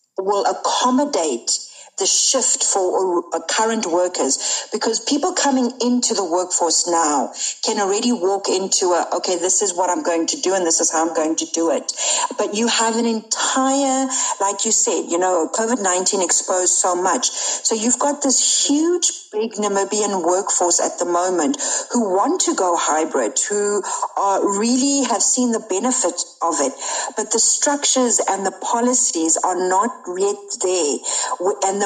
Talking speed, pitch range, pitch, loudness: 165 wpm, 180-255 Hz, 210 Hz, -18 LUFS